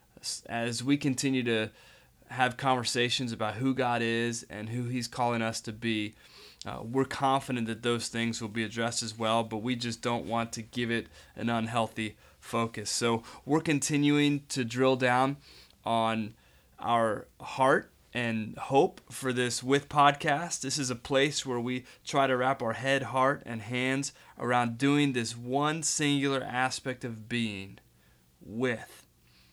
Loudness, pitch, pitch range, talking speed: -30 LUFS, 120 Hz, 115-135 Hz, 155 wpm